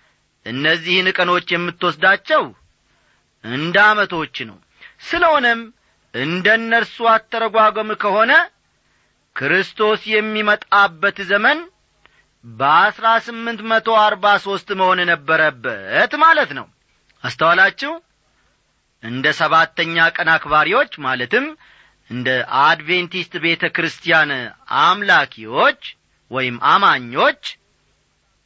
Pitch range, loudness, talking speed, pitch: 165-225 Hz, -16 LUFS, 75 wpm, 195 Hz